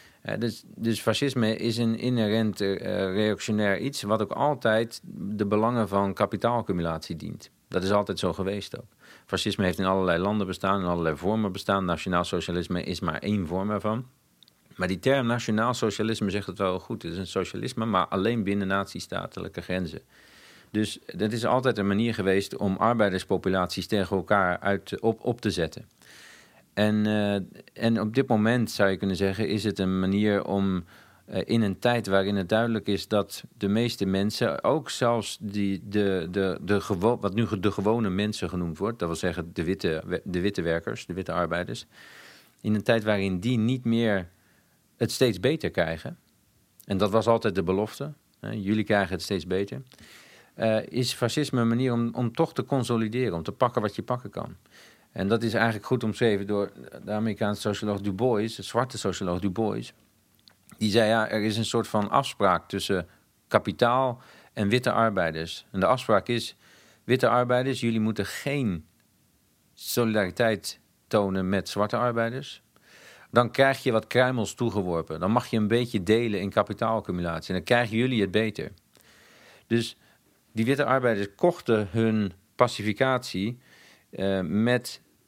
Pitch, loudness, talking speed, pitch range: 105 Hz, -27 LUFS, 170 wpm, 95-115 Hz